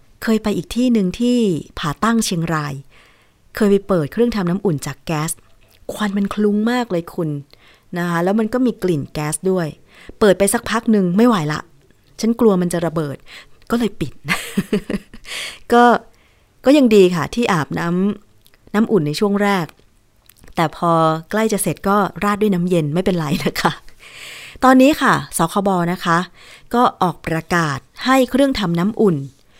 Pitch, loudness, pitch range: 185 Hz, -17 LUFS, 160-215 Hz